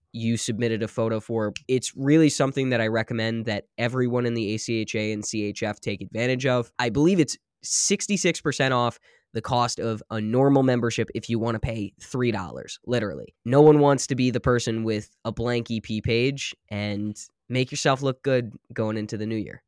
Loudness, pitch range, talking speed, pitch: -24 LUFS, 110-130 Hz, 185 wpm, 115 Hz